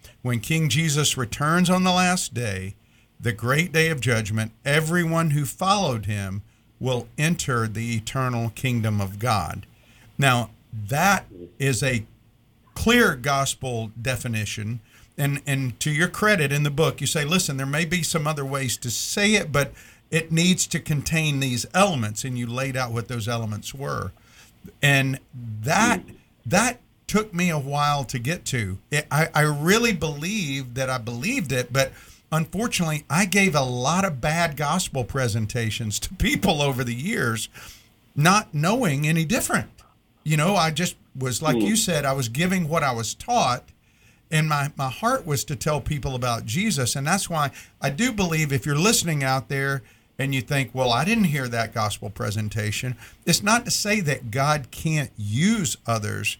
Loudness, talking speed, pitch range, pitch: -23 LUFS, 170 wpm, 115-160 Hz, 135 Hz